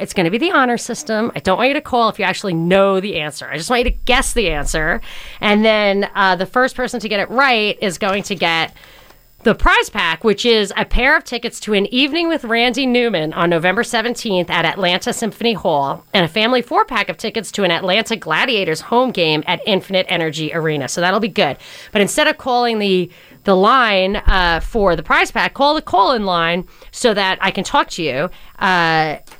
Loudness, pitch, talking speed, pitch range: -16 LUFS, 200 Hz, 220 wpm, 180-240 Hz